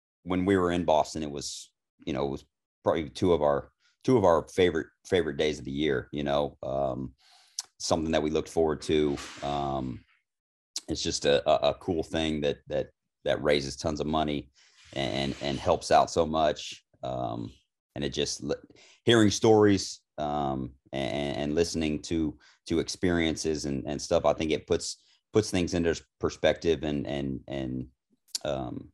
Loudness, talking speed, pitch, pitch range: -28 LUFS, 170 wpm, 75 Hz, 70-80 Hz